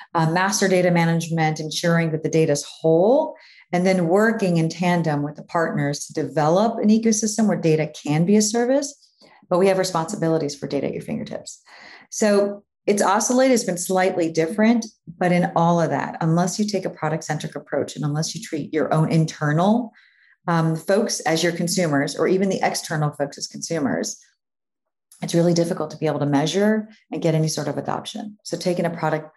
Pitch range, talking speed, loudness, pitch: 155-200 Hz, 190 wpm, -21 LUFS, 170 Hz